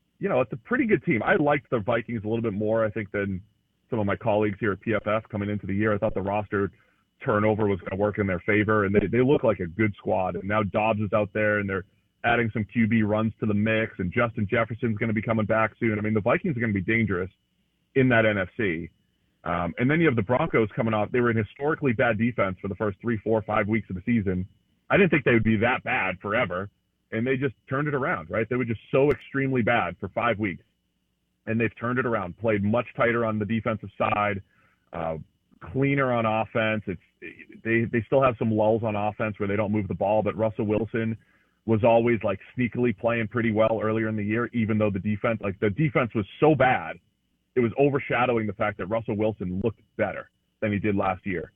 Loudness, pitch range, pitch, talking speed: -25 LUFS, 105-120 Hz, 110 Hz, 240 wpm